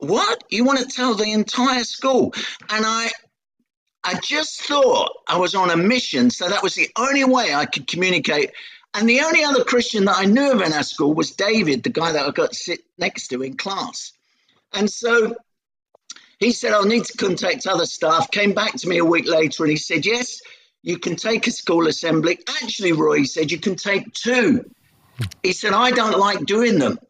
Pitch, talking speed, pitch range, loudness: 220 Hz, 205 wpm, 180-250 Hz, -19 LUFS